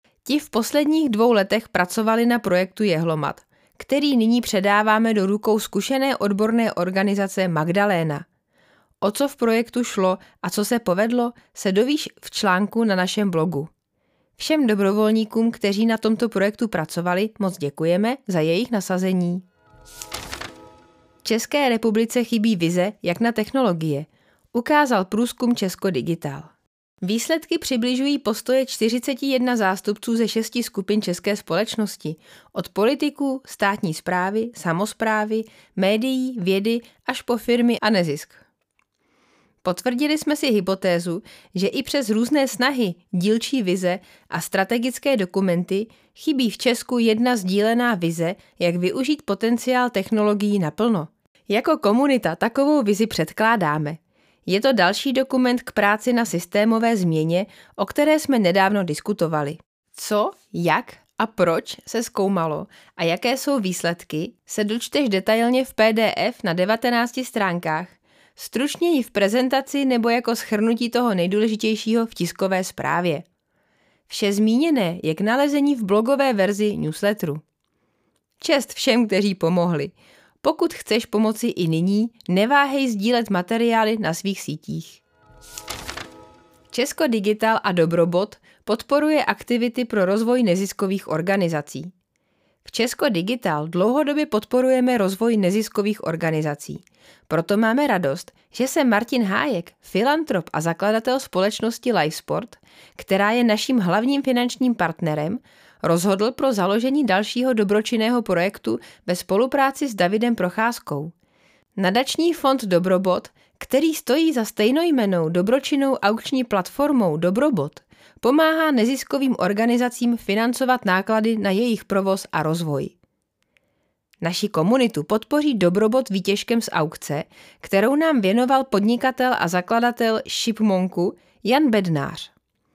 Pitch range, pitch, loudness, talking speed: 185-245 Hz, 215 Hz, -21 LUFS, 120 wpm